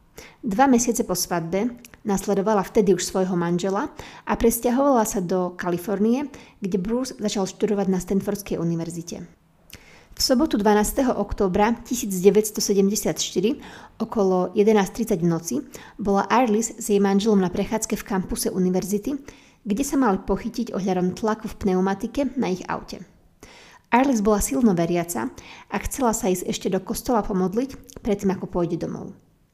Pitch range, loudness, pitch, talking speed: 190-230 Hz, -23 LUFS, 210 Hz, 135 wpm